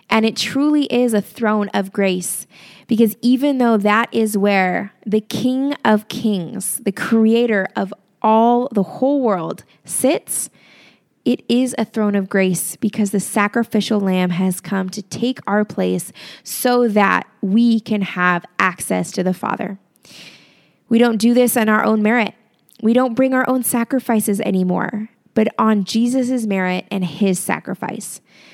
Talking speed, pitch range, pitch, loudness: 155 wpm, 195-235 Hz, 215 Hz, -18 LUFS